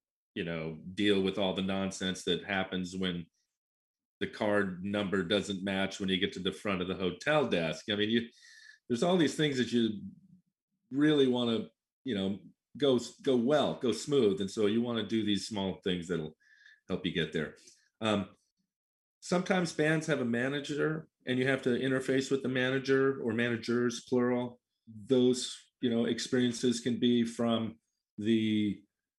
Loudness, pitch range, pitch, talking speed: -31 LUFS, 100-130 Hz, 115 Hz, 170 wpm